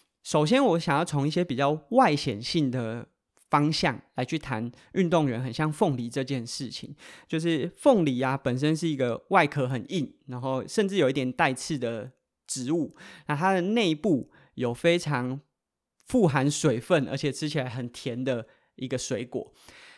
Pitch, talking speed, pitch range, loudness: 140 Hz, 240 characters per minute, 125-165 Hz, -27 LUFS